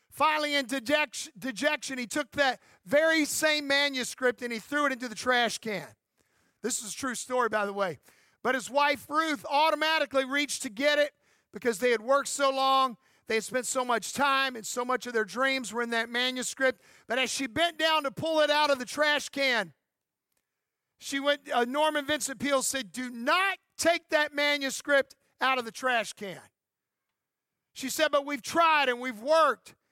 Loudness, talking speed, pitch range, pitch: -28 LUFS, 190 wpm, 245-295 Hz, 270 Hz